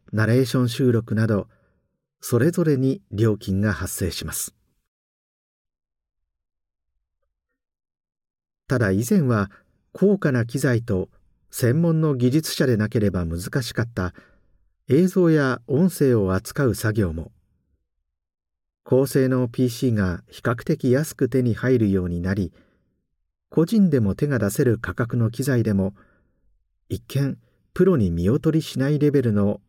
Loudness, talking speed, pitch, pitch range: -22 LUFS, 225 characters per minute, 110 Hz, 90-135 Hz